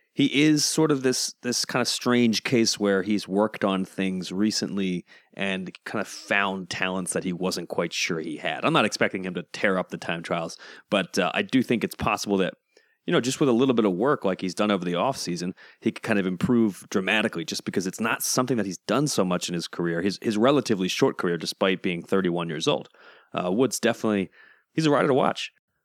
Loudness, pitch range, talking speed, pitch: -25 LUFS, 90-115 Hz, 230 wpm, 100 Hz